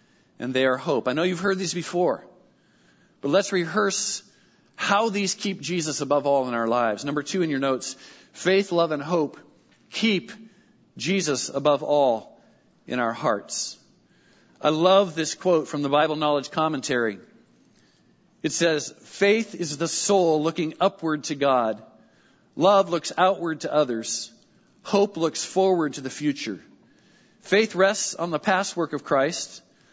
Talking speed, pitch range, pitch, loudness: 150 wpm, 145-190 Hz, 165 Hz, -24 LUFS